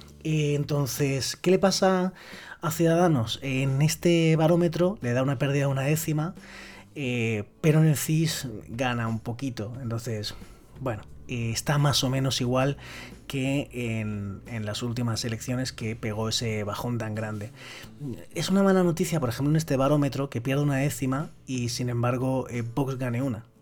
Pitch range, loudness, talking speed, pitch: 115-150 Hz, -26 LUFS, 165 wpm, 130 Hz